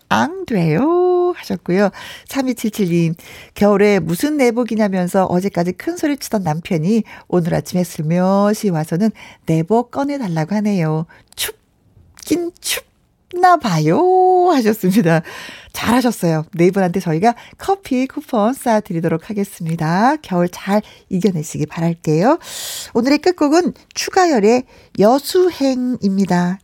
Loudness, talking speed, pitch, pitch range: -17 LUFS, 265 characters per minute, 210 Hz, 180-275 Hz